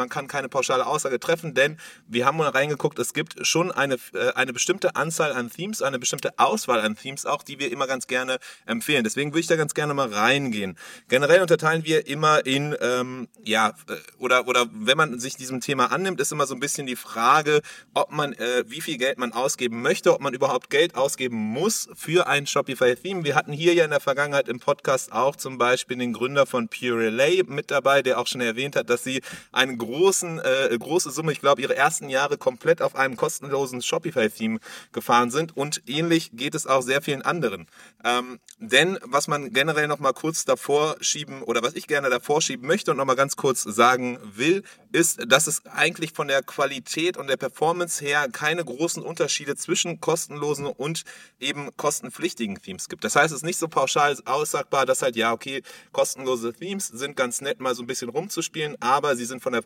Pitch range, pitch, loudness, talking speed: 130-170 Hz, 145 Hz, -23 LUFS, 205 wpm